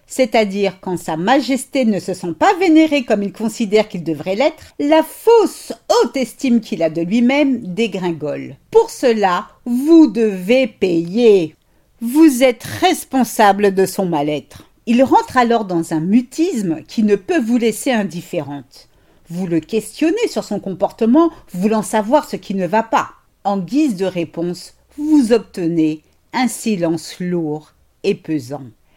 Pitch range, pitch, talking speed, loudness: 180-260 Hz, 220 Hz, 150 wpm, -16 LUFS